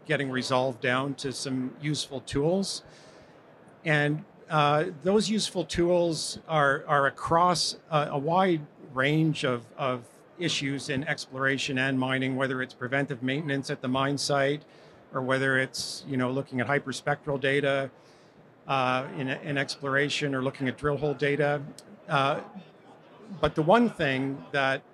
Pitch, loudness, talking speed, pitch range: 140 Hz, -27 LUFS, 140 wpm, 130-150 Hz